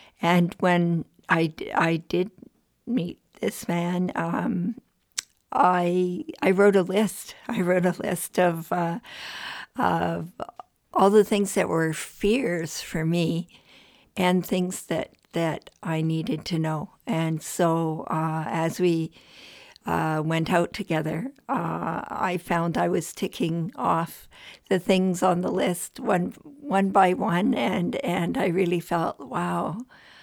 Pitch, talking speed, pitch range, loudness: 180 Hz, 135 wpm, 165-195 Hz, -25 LUFS